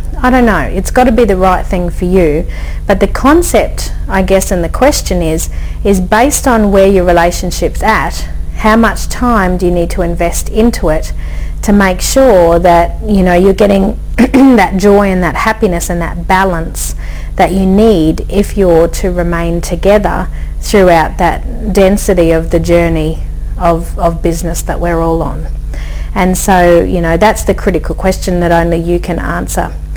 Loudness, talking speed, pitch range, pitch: -10 LUFS, 175 wpm, 170-200 Hz, 185 Hz